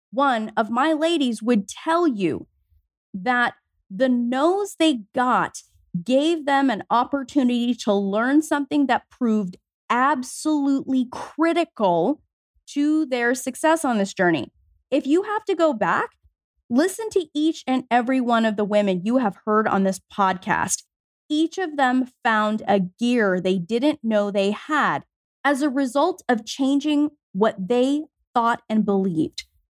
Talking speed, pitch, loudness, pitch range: 145 wpm, 250 Hz, -22 LUFS, 215-295 Hz